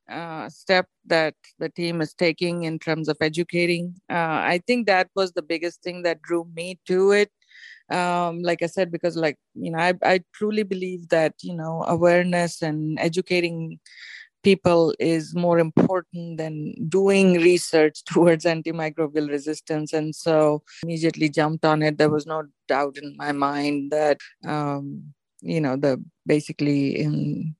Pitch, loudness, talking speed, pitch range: 165 Hz, -23 LUFS, 155 wpm, 155-175 Hz